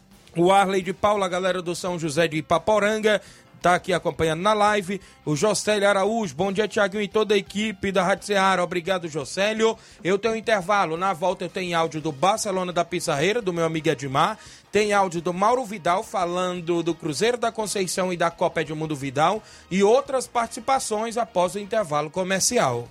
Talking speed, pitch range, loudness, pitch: 185 wpm, 170-210 Hz, -23 LUFS, 190 Hz